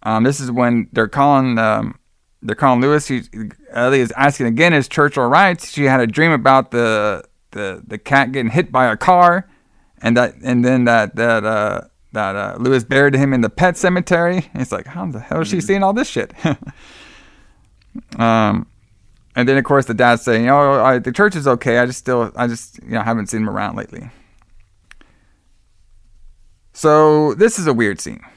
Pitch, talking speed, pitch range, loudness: 125 Hz, 200 wpm, 110-145 Hz, -15 LUFS